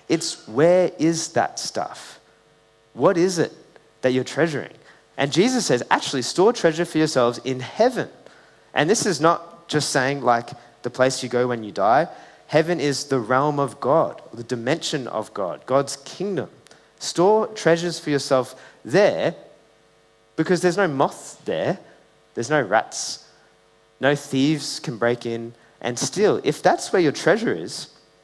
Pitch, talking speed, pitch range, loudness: 135 Hz, 155 wpm, 120-160 Hz, -22 LUFS